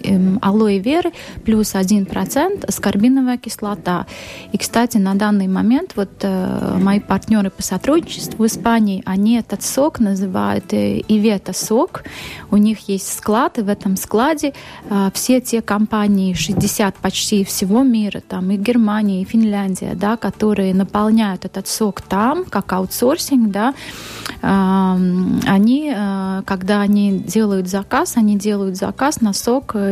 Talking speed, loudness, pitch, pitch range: 135 wpm, -17 LUFS, 205 Hz, 195-225 Hz